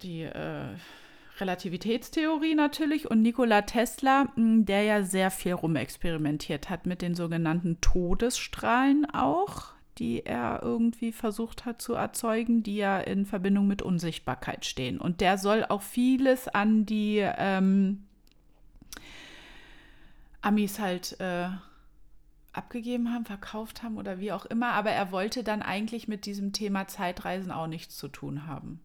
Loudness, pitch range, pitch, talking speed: -29 LUFS, 185-230 Hz, 205 Hz, 135 wpm